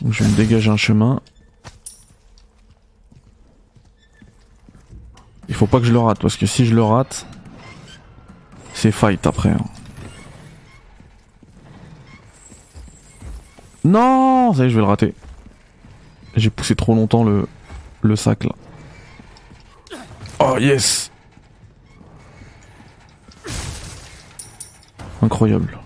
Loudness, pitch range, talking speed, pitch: -17 LUFS, 100-115 Hz, 95 wpm, 110 Hz